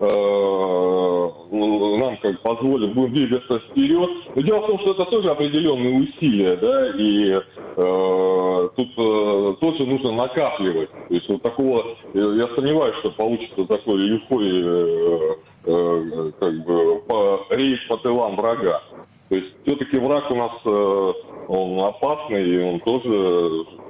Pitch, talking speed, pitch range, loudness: 115 Hz, 140 wpm, 95-145 Hz, -20 LUFS